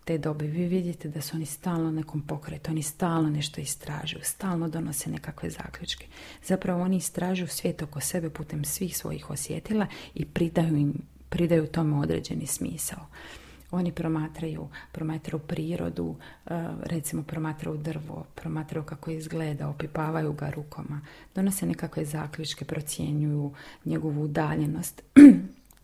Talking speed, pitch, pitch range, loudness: 125 wpm, 160 Hz, 150-170 Hz, -27 LUFS